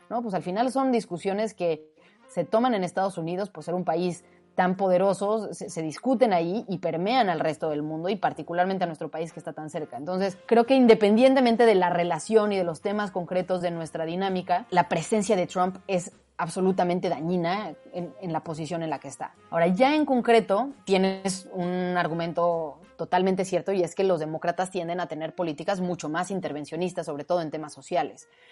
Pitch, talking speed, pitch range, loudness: 180 Hz, 195 wpm, 170-195 Hz, -26 LUFS